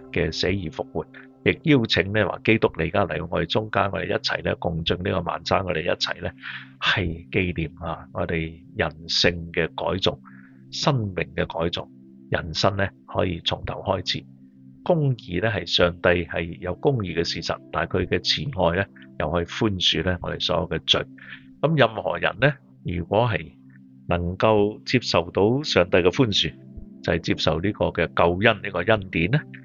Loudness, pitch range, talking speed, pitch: -23 LUFS, 65-100 Hz, 255 characters per minute, 85 Hz